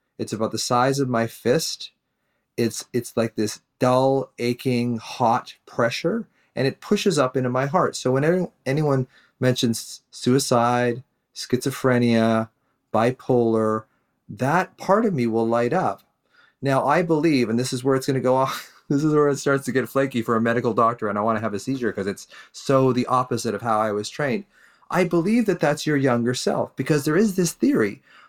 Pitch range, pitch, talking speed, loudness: 115-140 Hz, 125 Hz, 190 wpm, -22 LUFS